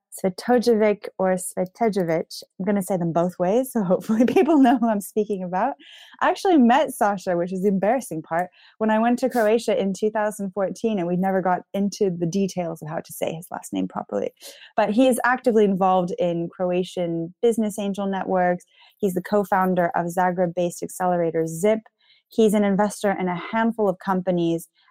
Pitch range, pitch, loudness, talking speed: 180-220 Hz, 195 Hz, -22 LUFS, 185 wpm